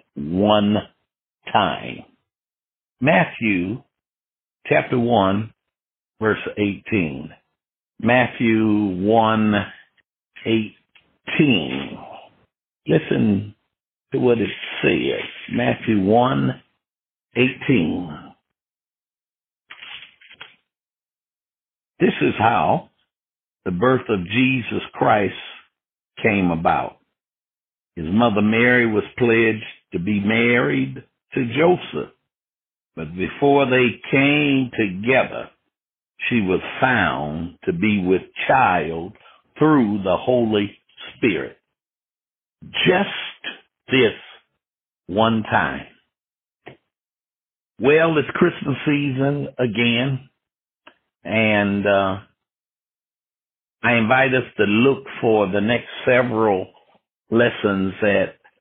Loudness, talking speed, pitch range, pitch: -19 LUFS, 80 wpm, 105-130 Hz, 115 Hz